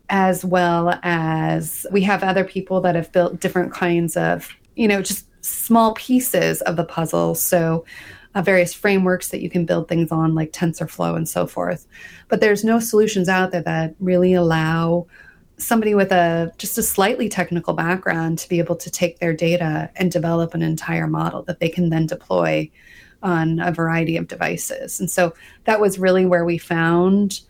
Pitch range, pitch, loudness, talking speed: 165-190 Hz, 175 Hz, -19 LUFS, 180 wpm